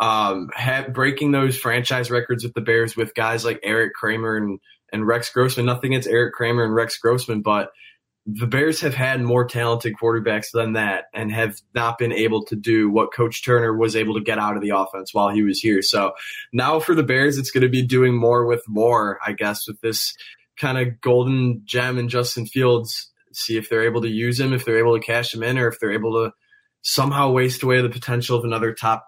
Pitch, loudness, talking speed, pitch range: 115 Hz, -20 LUFS, 225 wpm, 110-125 Hz